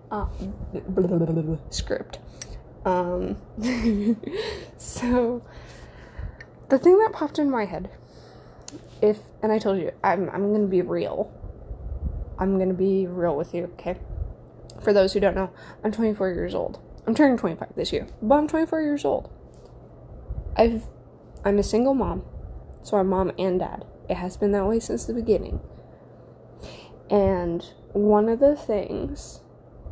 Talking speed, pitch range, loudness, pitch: 150 wpm, 180-235 Hz, -24 LUFS, 205 Hz